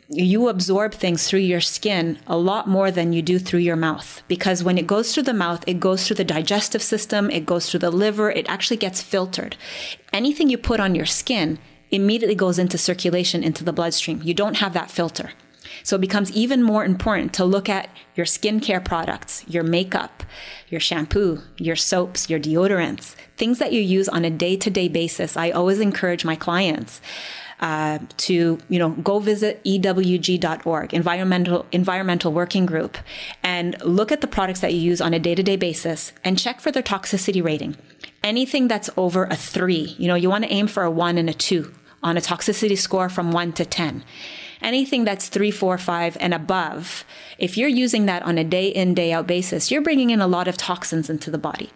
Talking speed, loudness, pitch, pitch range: 195 wpm, -21 LUFS, 180 Hz, 170-205 Hz